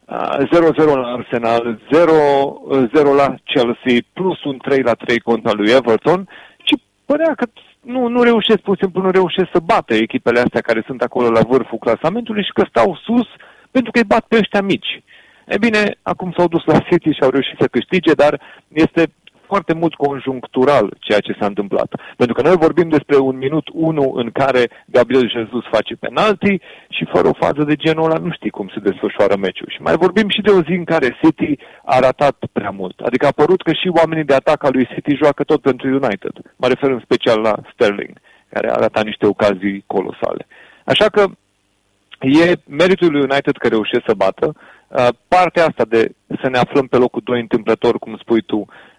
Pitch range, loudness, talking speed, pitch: 120-180 Hz, -15 LUFS, 190 wpm, 145 Hz